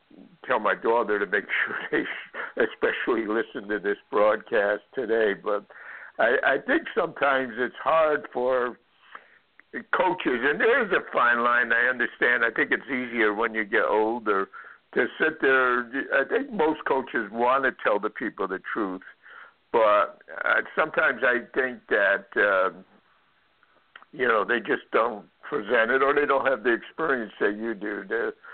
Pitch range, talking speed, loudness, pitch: 115-145 Hz, 160 wpm, -24 LUFS, 125 Hz